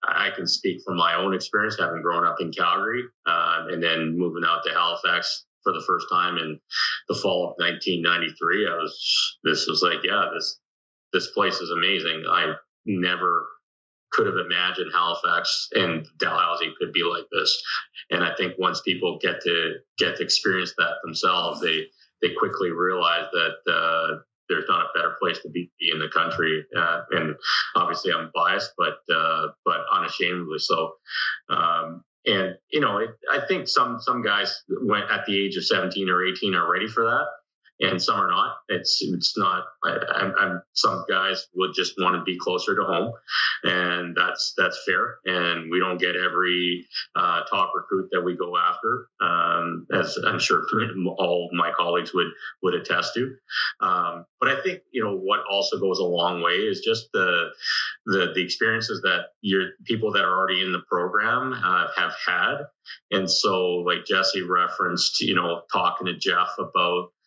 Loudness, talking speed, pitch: -23 LUFS, 180 wpm, 125 Hz